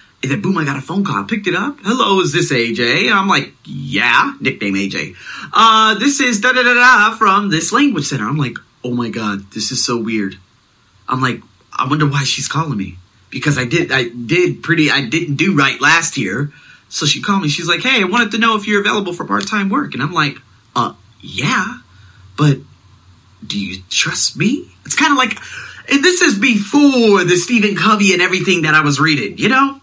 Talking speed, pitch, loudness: 215 wpm, 165 Hz, -14 LUFS